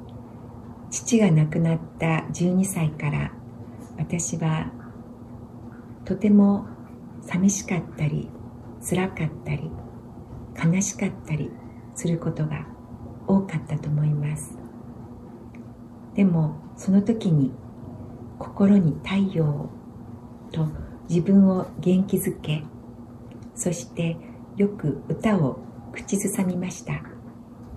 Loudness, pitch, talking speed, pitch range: -24 LUFS, 145 Hz, 170 characters per minute, 120-175 Hz